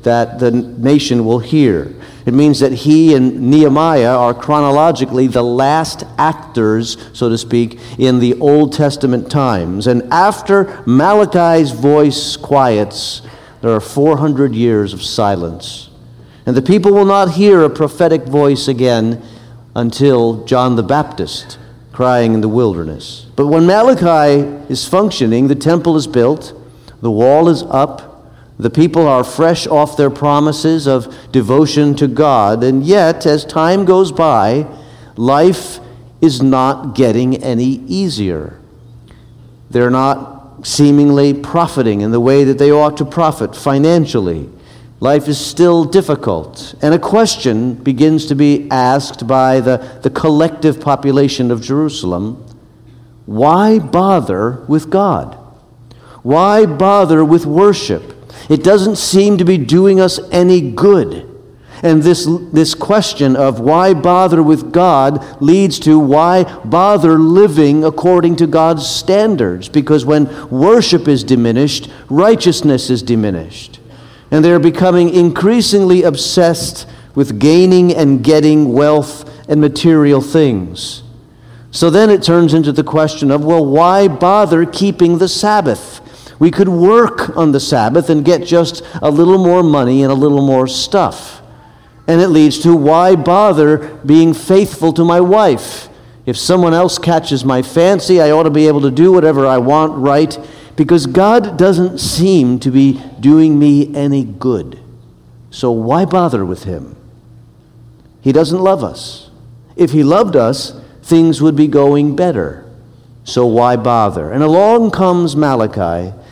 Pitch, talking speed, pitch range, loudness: 145 Hz, 140 wpm, 125-165 Hz, -11 LUFS